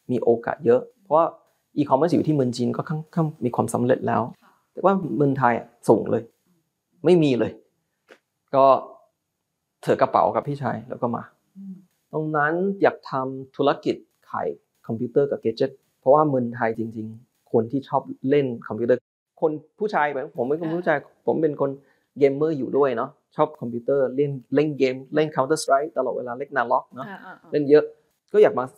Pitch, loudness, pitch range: 145 Hz, -23 LUFS, 130-155 Hz